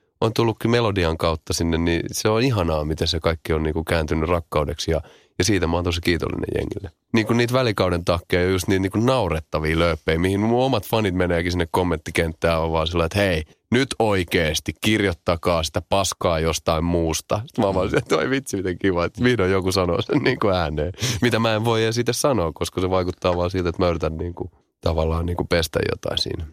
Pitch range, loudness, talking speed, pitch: 85-105 Hz, -22 LUFS, 205 wpm, 90 Hz